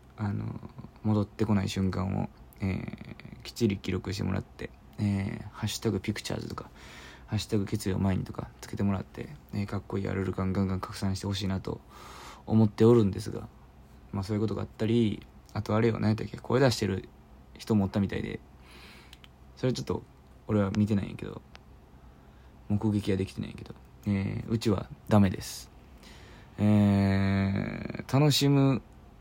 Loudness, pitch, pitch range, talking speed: -29 LUFS, 105 Hz, 95-110 Hz, 355 characters per minute